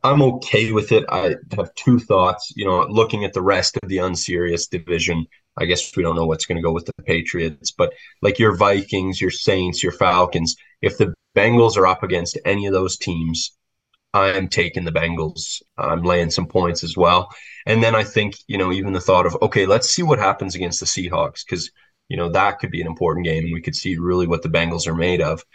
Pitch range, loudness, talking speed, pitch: 85-100 Hz, -19 LUFS, 225 wpm, 90 Hz